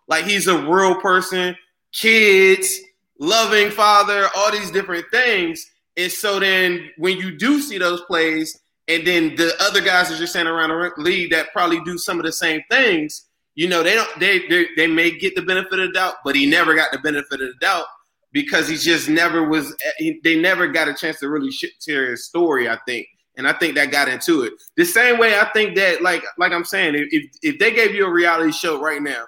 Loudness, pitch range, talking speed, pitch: -17 LUFS, 165-215 Hz, 220 wpm, 185 Hz